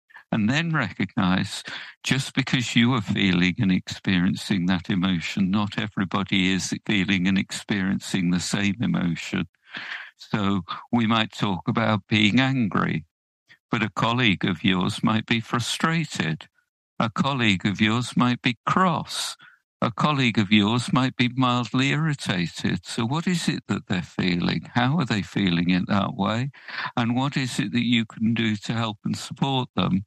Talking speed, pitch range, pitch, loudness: 155 wpm, 100-130 Hz, 115 Hz, -24 LUFS